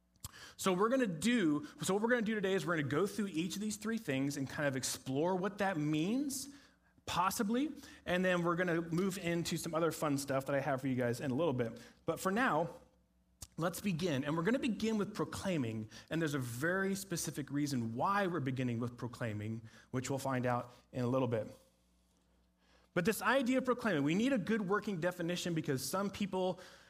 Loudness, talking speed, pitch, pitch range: -36 LUFS, 220 wpm, 165 Hz, 130-200 Hz